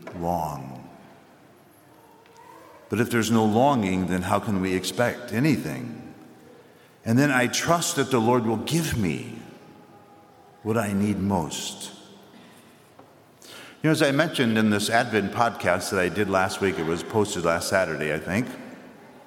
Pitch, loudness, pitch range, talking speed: 105 Hz, -24 LUFS, 95-120 Hz, 145 wpm